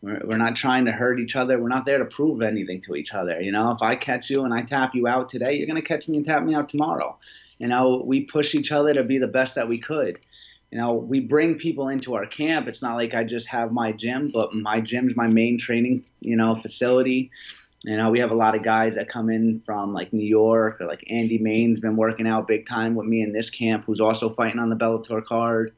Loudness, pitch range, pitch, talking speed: -23 LUFS, 110-130 Hz, 115 Hz, 260 wpm